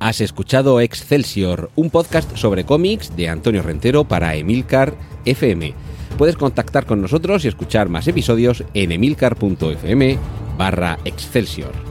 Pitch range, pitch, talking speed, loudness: 90-135 Hz, 115 Hz, 125 wpm, -17 LUFS